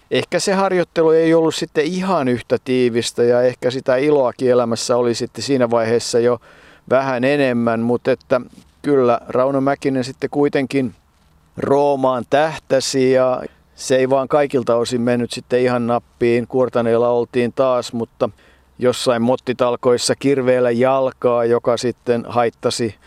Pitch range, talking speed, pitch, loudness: 120-135 Hz, 135 wpm, 125 Hz, -17 LUFS